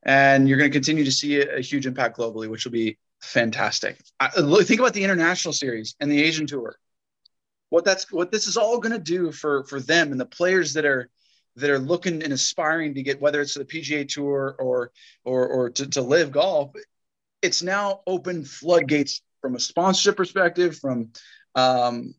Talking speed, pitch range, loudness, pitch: 190 wpm, 135-175 Hz, -22 LUFS, 145 Hz